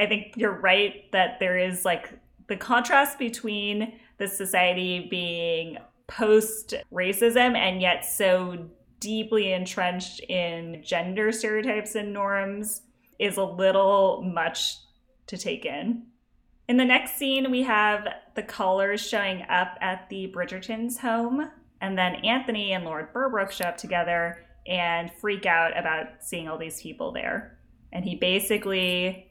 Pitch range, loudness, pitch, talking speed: 180-220 Hz, -25 LUFS, 195 Hz, 140 wpm